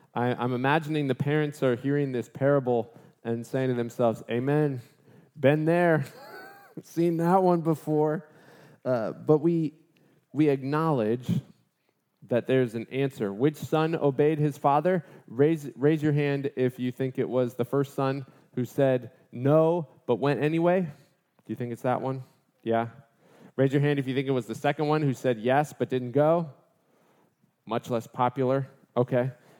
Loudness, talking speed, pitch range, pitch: -27 LUFS, 160 wpm, 125-155 Hz, 140 Hz